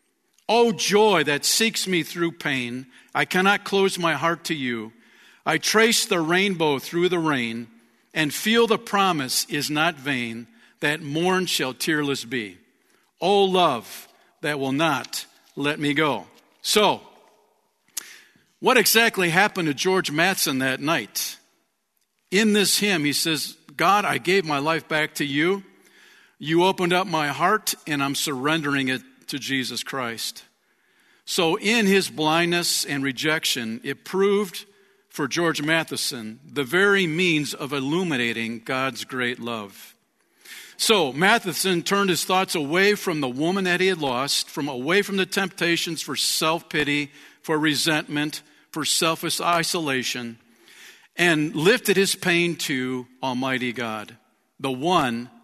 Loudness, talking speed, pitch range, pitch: -22 LUFS, 140 wpm, 135-185 Hz, 155 Hz